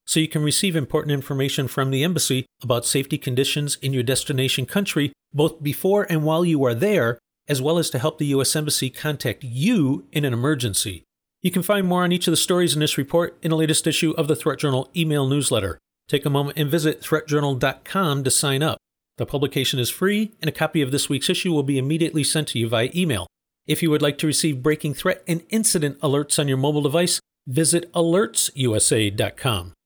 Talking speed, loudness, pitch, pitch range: 205 wpm, -21 LUFS, 150 Hz, 135-160 Hz